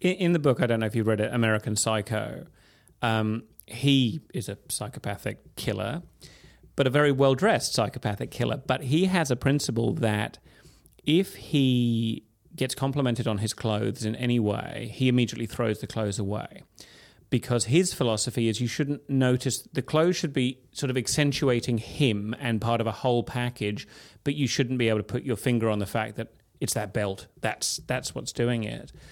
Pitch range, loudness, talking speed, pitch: 110-135 Hz, -27 LUFS, 185 wpm, 120 Hz